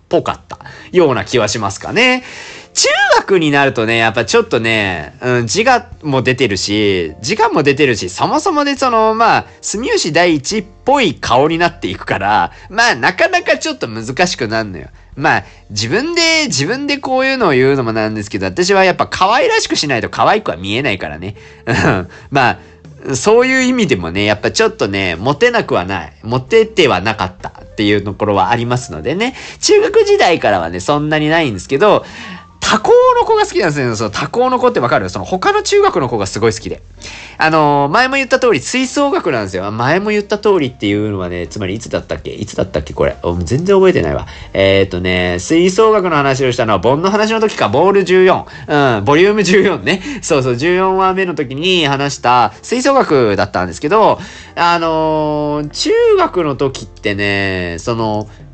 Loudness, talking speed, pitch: -13 LUFS, 375 characters per minute, 150 Hz